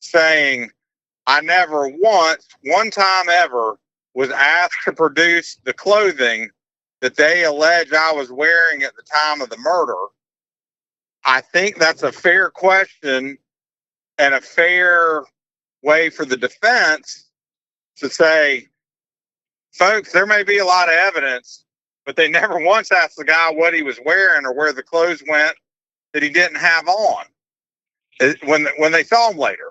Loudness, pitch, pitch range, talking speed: -15 LUFS, 165 Hz, 155-185 Hz, 150 wpm